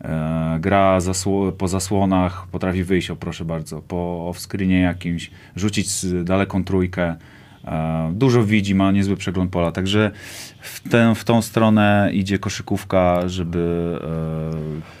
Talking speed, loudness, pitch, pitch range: 125 wpm, -20 LUFS, 95 Hz, 85-100 Hz